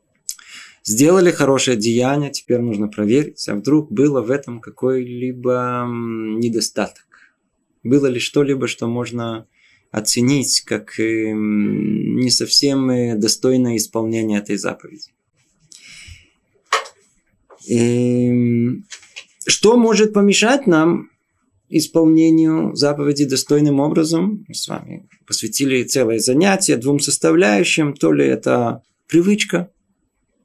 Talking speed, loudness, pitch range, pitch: 95 wpm, -17 LUFS, 115-155 Hz, 130 Hz